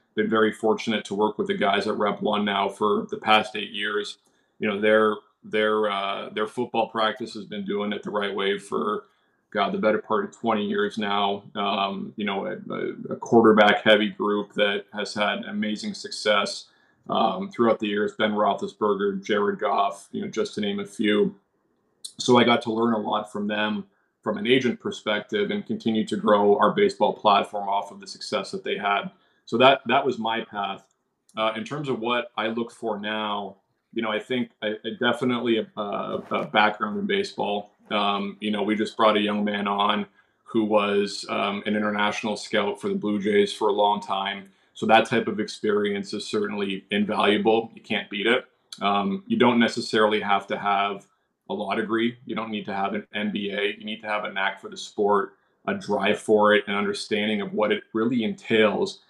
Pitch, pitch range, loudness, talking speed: 105 Hz, 100-110 Hz, -24 LUFS, 200 wpm